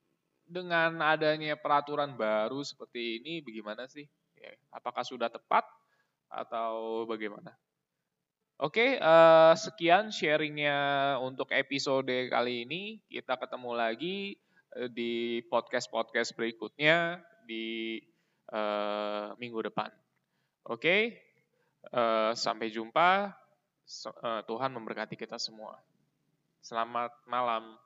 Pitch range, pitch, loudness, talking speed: 115-155 Hz, 120 Hz, -30 LUFS, 80 wpm